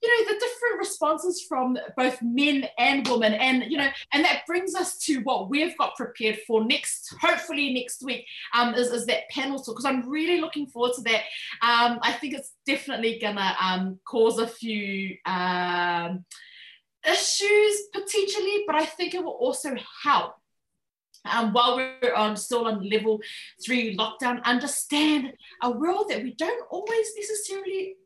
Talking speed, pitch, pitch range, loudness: 165 wpm, 260 Hz, 230-335 Hz, -25 LUFS